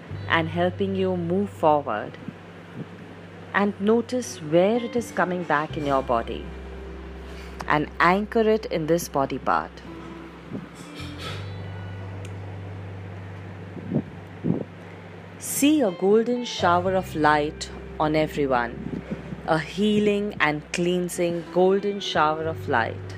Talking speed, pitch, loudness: 100 wpm, 150 Hz, -24 LUFS